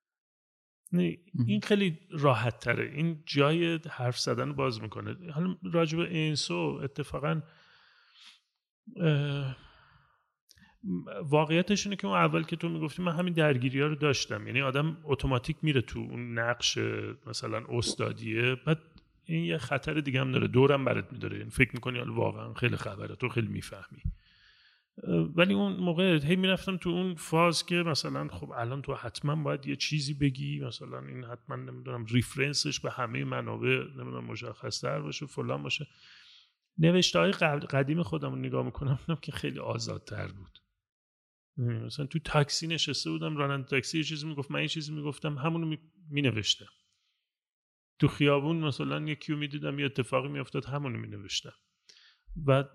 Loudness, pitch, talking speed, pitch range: -30 LUFS, 145 Hz, 145 wpm, 120-160 Hz